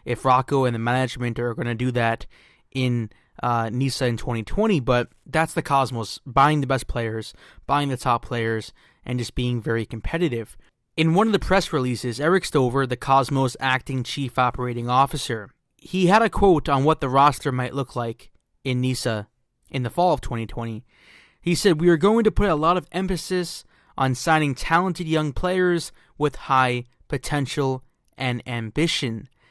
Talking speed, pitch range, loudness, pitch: 175 wpm, 120-160 Hz, -23 LUFS, 130 Hz